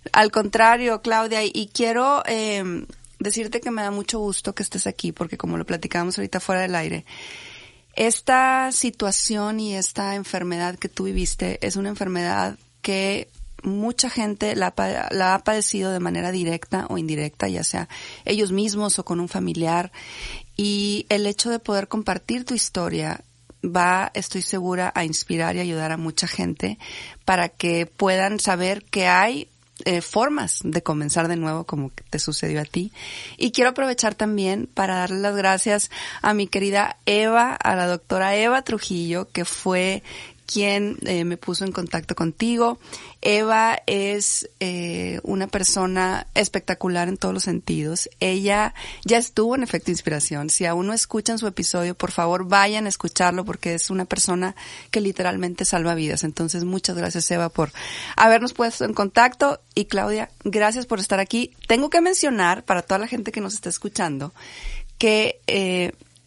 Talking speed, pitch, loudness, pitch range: 160 wpm, 195 Hz, -22 LUFS, 175-215 Hz